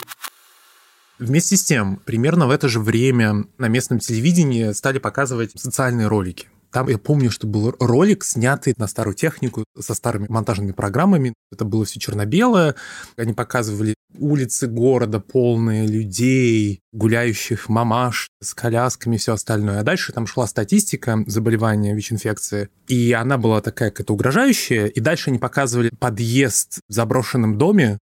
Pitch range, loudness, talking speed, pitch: 110-130 Hz, -19 LUFS, 145 wpm, 115 Hz